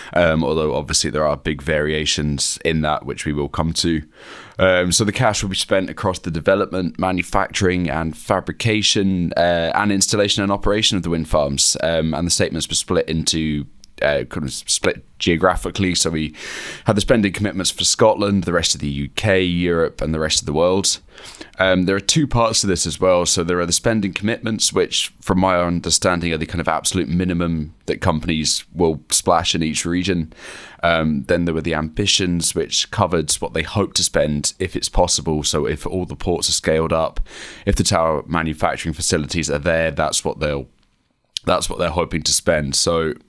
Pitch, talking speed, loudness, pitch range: 85 Hz, 195 wpm, -18 LUFS, 80-95 Hz